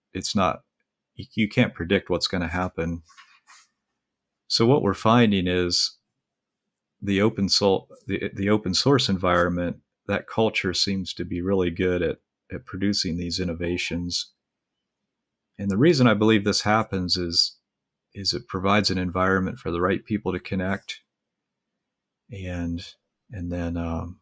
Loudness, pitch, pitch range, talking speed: -24 LUFS, 95 Hz, 90-100 Hz, 140 wpm